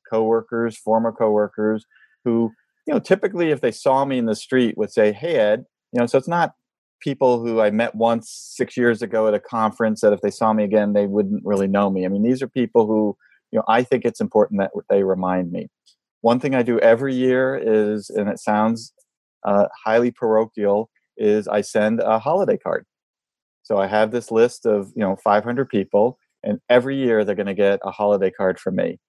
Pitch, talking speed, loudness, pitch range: 110 Hz, 210 wpm, -20 LUFS, 105-120 Hz